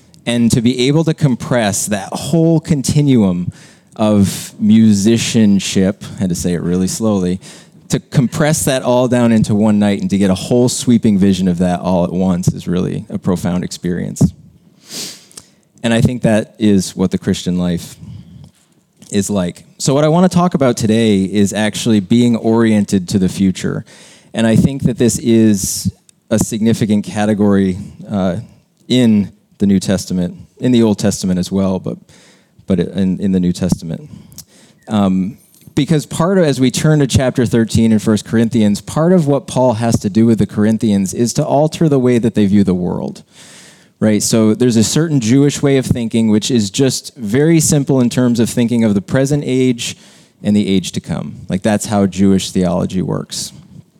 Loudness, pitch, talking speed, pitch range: -14 LUFS, 115 Hz, 180 wpm, 100-130 Hz